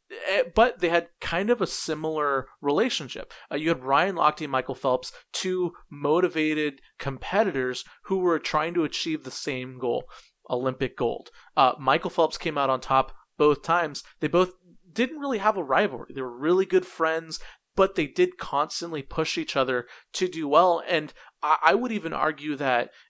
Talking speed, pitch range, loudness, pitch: 175 wpm, 135-185 Hz, -26 LUFS, 160 Hz